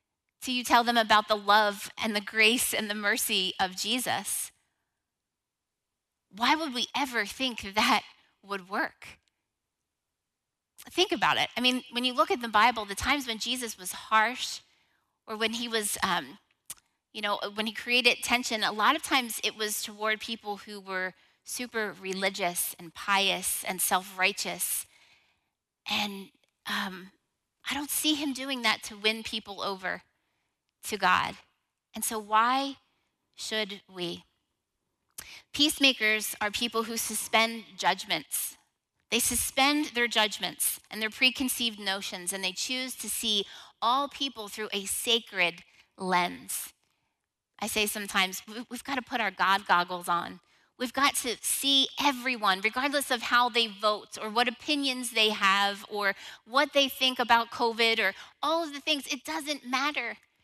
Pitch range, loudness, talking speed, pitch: 205-255 Hz, -28 LUFS, 150 wpm, 220 Hz